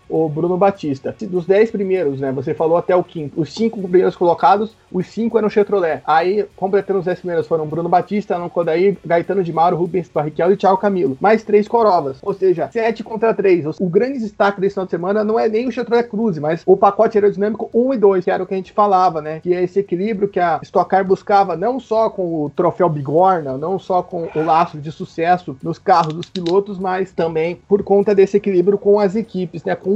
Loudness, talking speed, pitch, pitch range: -17 LUFS, 225 wpm, 190 Hz, 170-205 Hz